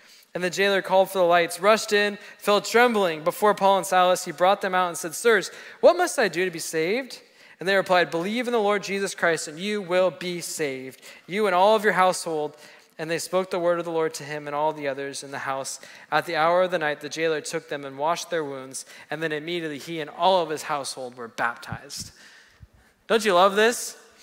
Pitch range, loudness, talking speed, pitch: 155-195 Hz, -23 LUFS, 235 wpm, 175 Hz